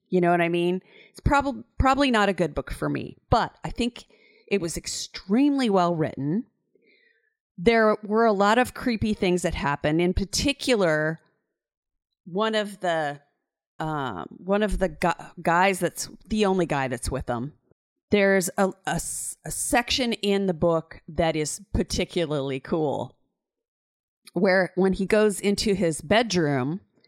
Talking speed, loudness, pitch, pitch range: 150 wpm, -24 LUFS, 190 Hz, 165-220 Hz